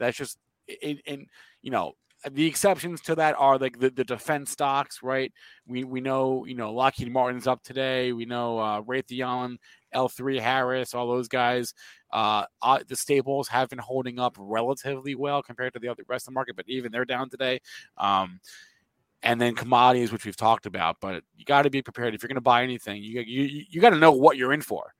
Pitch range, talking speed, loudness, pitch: 120-135 Hz, 205 wpm, -26 LUFS, 130 Hz